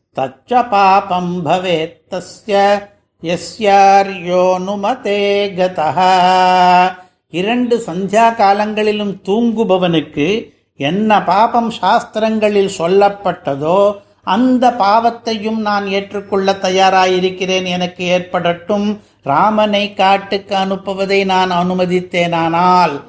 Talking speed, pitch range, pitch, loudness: 70 wpm, 180-205 Hz, 195 Hz, -14 LUFS